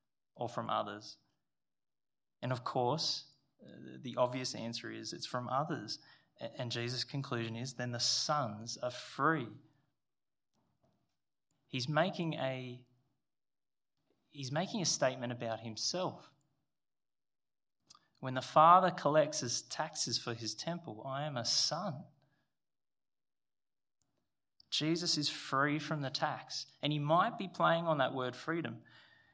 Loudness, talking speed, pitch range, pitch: -35 LUFS, 120 wpm, 125-155 Hz, 135 Hz